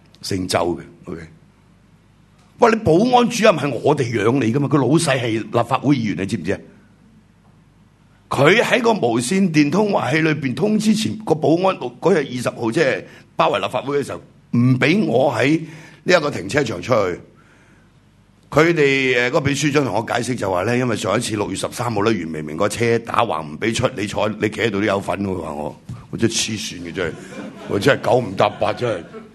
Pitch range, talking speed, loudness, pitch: 110-155 Hz, 295 characters per minute, -18 LUFS, 125 Hz